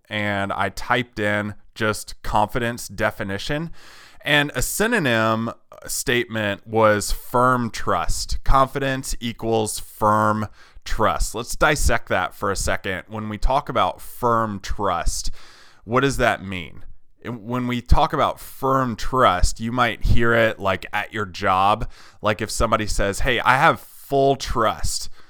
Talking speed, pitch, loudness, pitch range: 135 wpm, 110 Hz, -21 LUFS, 100-120 Hz